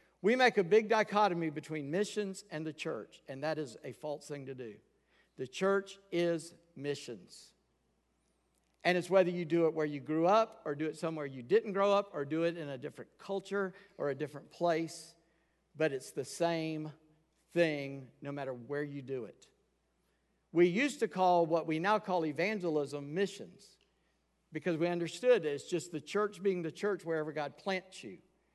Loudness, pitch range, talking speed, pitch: -34 LUFS, 150-195 Hz, 180 wpm, 165 Hz